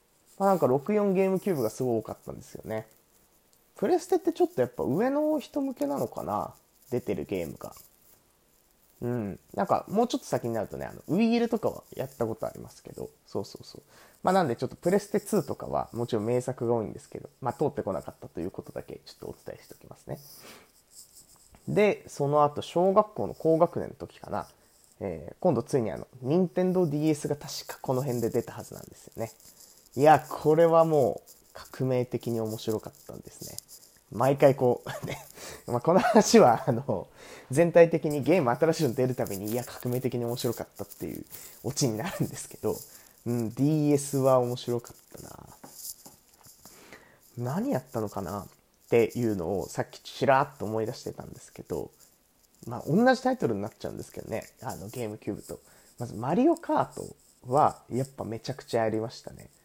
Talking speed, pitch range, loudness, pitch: 380 characters per minute, 115-180 Hz, -28 LUFS, 130 Hz